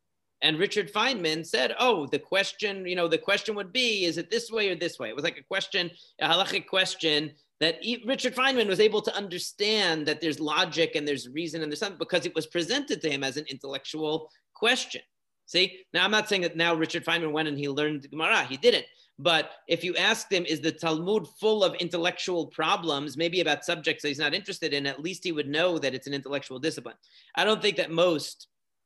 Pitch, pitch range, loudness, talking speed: 170 Hz, 155-200 Hz, -27 LUFS, 215 wpm